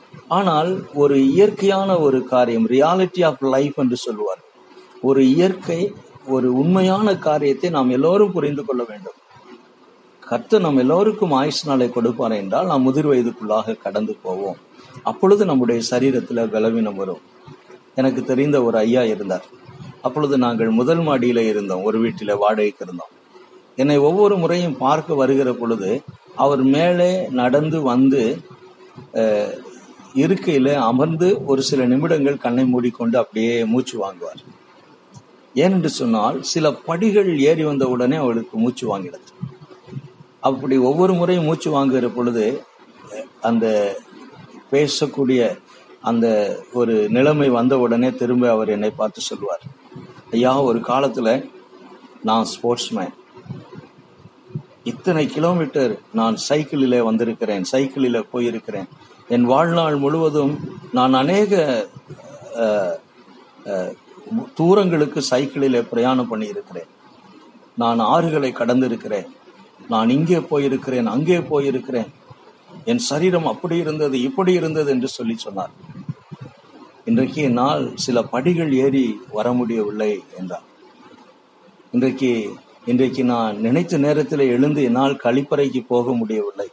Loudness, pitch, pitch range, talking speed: -19 LUFS, 135 Hz, 120-160 Hz, 105 wpm